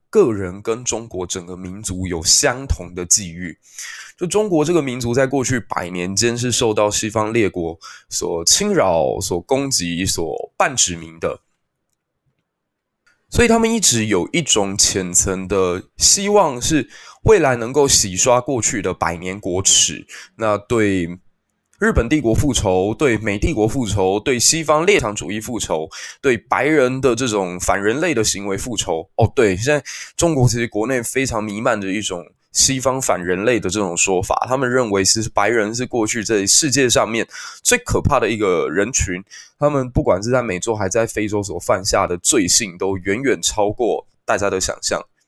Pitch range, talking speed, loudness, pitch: 95-130 Hz, 255 characters per minute, -17 LUFS, 110 Hz